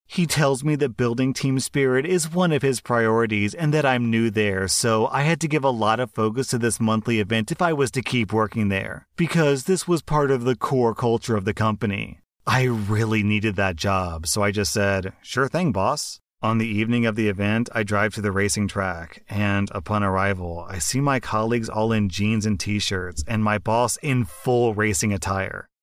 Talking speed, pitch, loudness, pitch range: 215 wpm, 110 Hz, -22 LUFS, 105-130 Hz